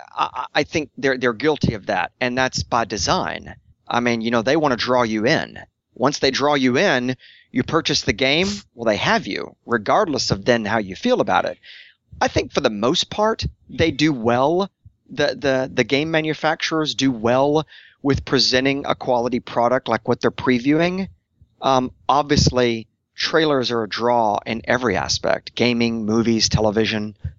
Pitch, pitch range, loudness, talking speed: 130 Hz, 120-150 Hz, -20 LUFS, 175 wpm